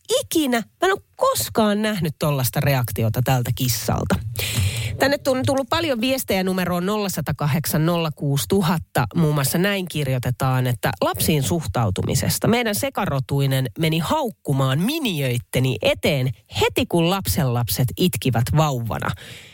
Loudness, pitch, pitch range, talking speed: -21 LUFS, 150 Hz, 125-200 Hz, 105 wpm